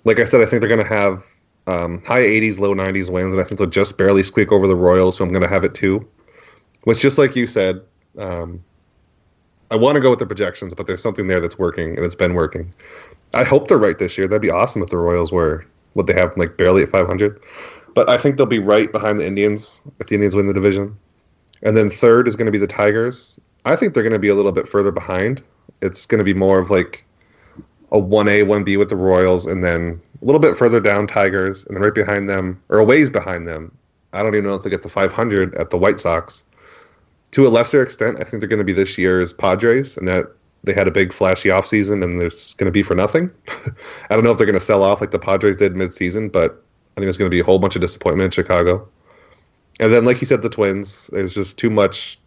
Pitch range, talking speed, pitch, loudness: 90-105 Hz, 255 wpm, 100 Hz, -16 LUFS